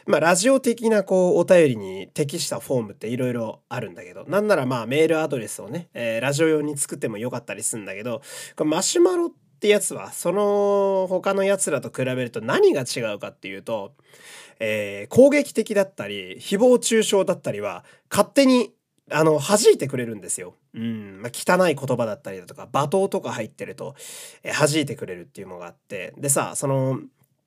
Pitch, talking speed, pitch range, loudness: 185 Hz, 390 characters per minute, 140-215 Hz, -22 LUFS